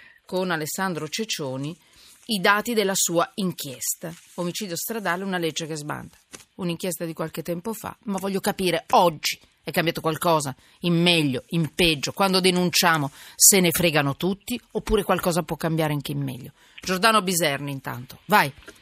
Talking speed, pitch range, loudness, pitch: 150 wpm, 155-190 Hz, -23 LUFS, 170 Hz